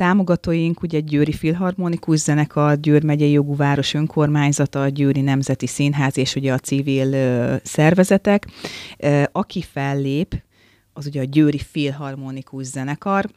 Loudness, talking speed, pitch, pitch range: -19 LUFS, 130 wpm, 145 Hz, 135-160 Hz